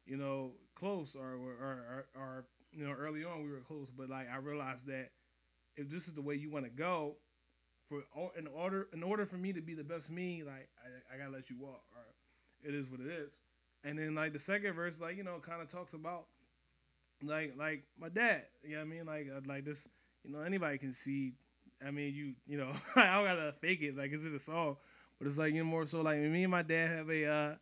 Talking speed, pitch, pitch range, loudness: 245 wpm, 145 Hz, 135-165 Hz, -39 LUFS